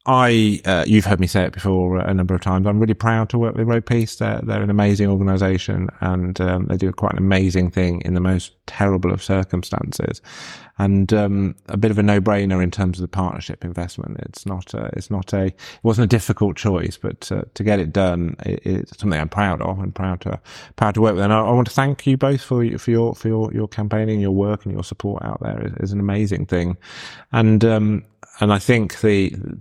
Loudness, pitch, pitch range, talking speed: -19 LUFS, 100 Hz, 95-110 Hz, 235 wpm